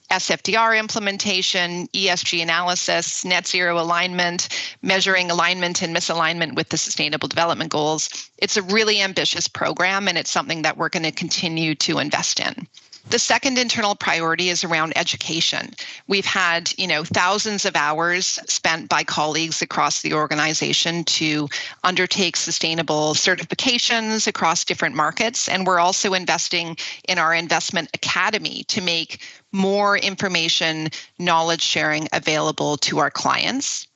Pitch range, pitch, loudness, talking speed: 160-195 Hz, 175 Hz, -19 LUFS, 135 wpm